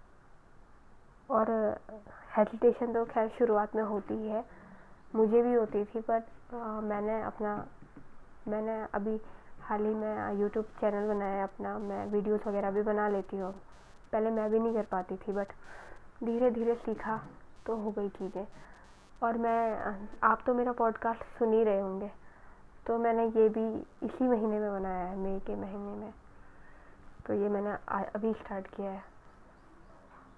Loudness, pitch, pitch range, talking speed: -32 LUFS, 215 Hz, 205-225 Hz, 155 wpm